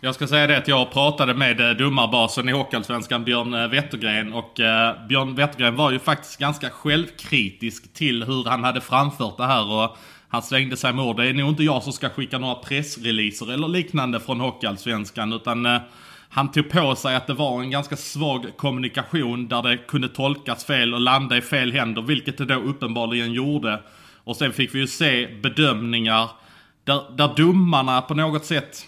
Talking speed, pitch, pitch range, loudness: 185 wpm, 130 Hz, 120-140 Hz, -21 LUFS